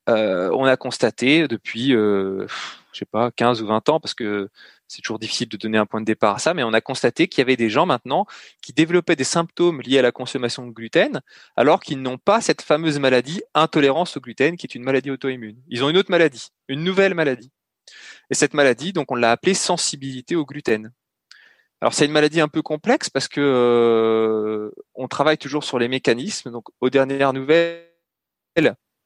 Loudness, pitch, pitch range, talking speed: -20 LUFS, 135 Hz, 120-160 Hz, 205 wpm